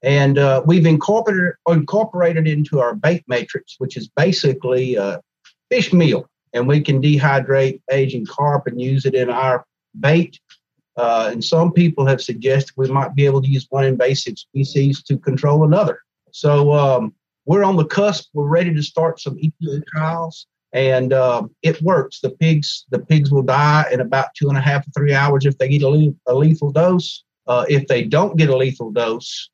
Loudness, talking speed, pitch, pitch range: -17 LUFS, 190 wpm, 140 Hz, 130-160 Hz